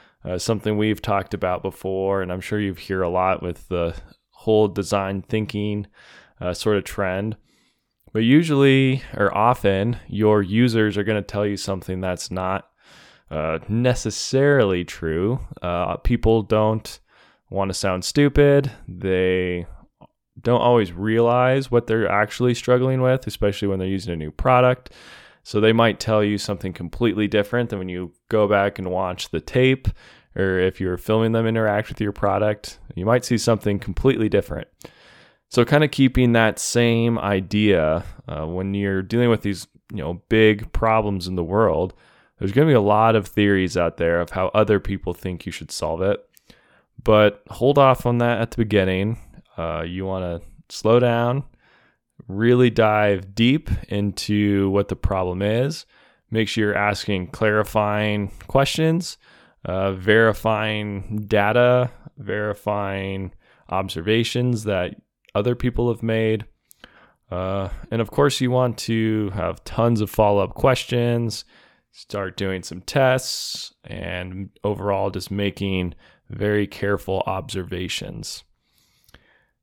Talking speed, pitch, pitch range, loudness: 150 wpm, 105 Hz, 95-115 Hz, -21 LUFS